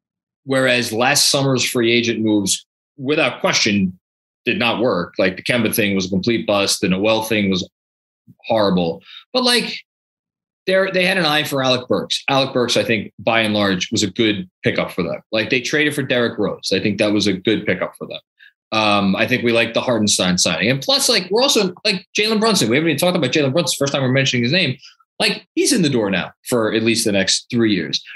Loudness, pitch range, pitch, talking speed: -17 LUFS, 105-150 Hz, 120 Hz, 220 wpm